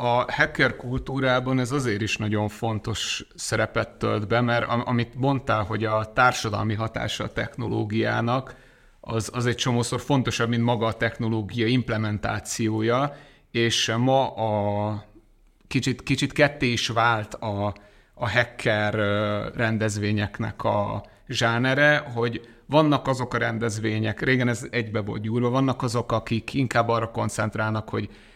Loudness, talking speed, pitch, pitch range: -24 LUFS, 130 wpm, 115 Hz, 110-125 Hz